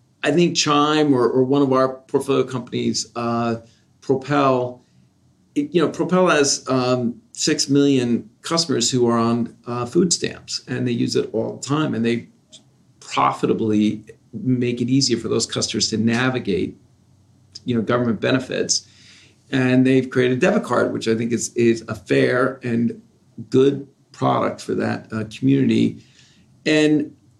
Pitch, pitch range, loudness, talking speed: 125 Hz, 115-140 Hz, -20 LUFS, 150 wpm